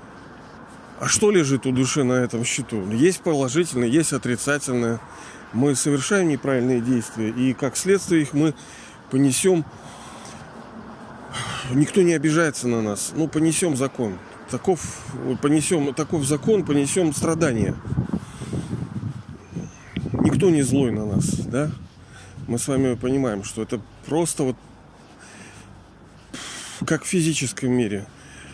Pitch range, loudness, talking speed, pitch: 115-155 Hz, -22 LUFS, 115 wpm, 135 Hz